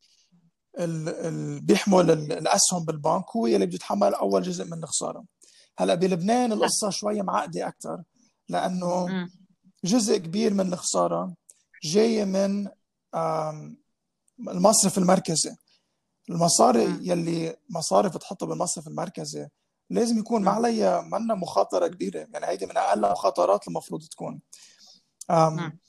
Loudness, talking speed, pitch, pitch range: -25 LUFS, 105 wpm, 185 Hz, 165-210 Hz